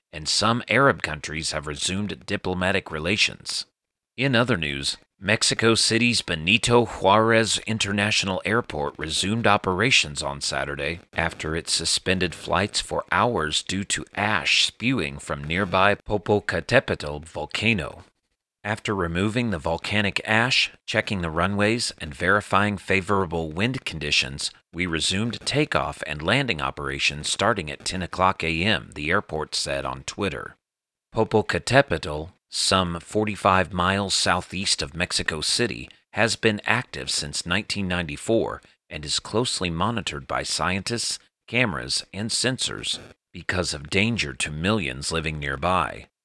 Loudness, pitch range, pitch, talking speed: -23 LUFS, 80-105 Hz, 95 Hz, 125 wpm